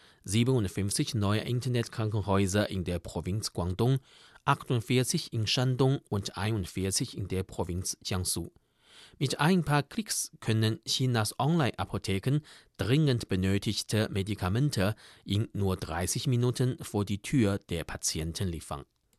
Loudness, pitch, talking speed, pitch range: -30 LUFS, 110 Hz, 115 wpm, 95-130 Hz